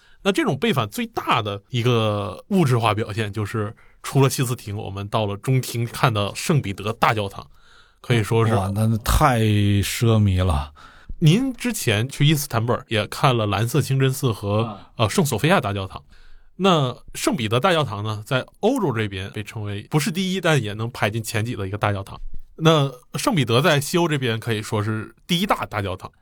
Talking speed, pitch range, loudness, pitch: 285 characters per minute, 105-140 Hz, -21 LUFS, 115 Hz